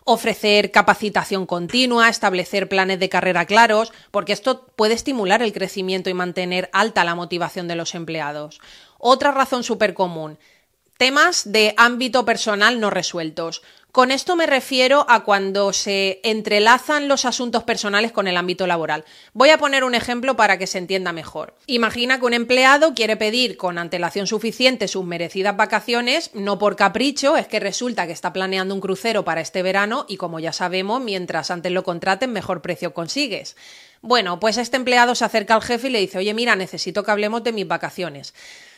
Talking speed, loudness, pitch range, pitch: 175 wpm, -18 LUFS, 185-240 Hz, 205 Hz